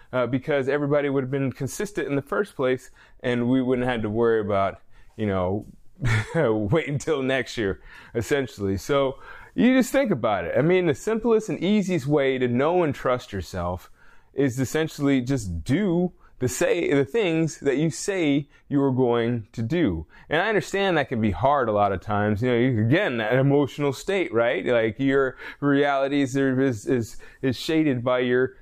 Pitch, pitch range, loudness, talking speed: 135 Hz, 120-150 Hz, -24 LUFS, 180 wpm